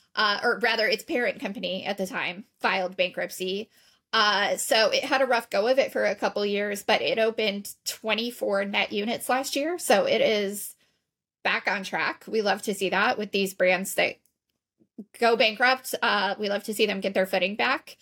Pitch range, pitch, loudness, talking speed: 195-230 Hz, 210 Hz, -25 LUFS, 195 wpm